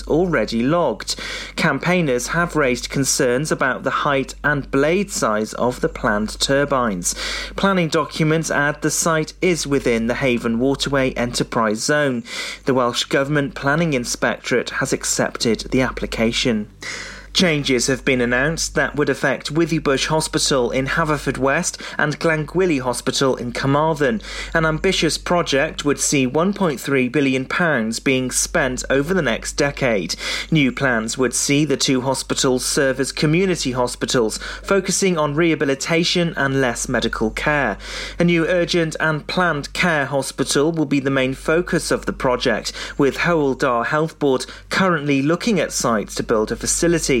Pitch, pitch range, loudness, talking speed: 145 Hz, 130-165 Hz, -19 LUFS, 140 wpm